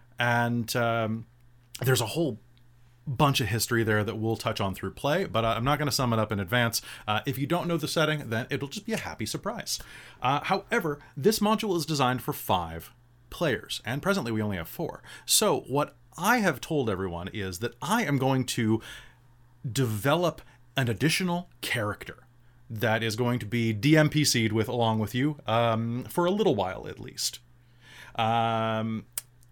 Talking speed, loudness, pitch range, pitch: 180 wpm, -27 LUFS, 115-145 Hz, 120 Hz